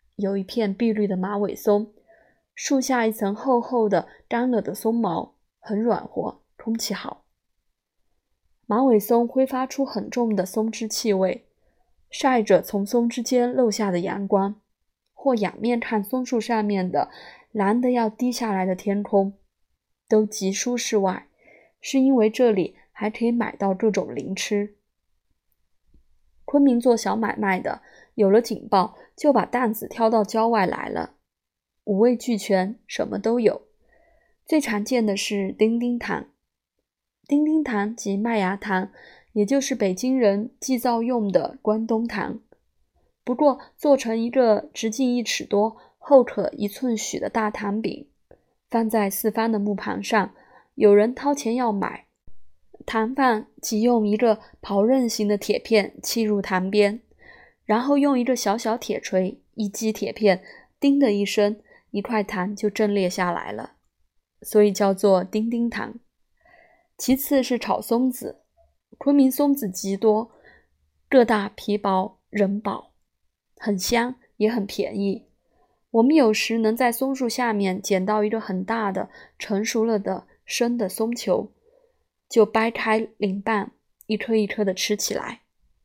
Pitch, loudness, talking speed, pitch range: 220 Hz, -23 LUFS, 205 characters per minute, 205-240 Hz